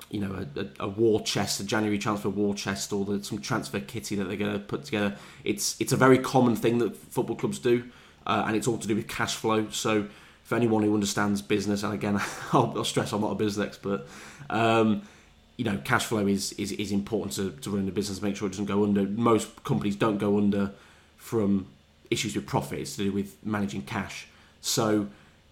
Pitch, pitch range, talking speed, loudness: 105 Hz, 100-110 Hz, 215 wpm, -28 LUFS